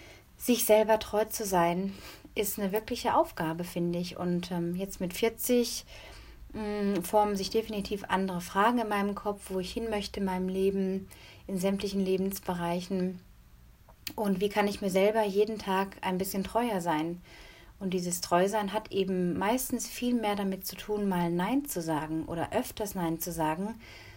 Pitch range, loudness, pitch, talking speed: 180-215 Hz, -30 LUFS, 195 Hz, 165 wpm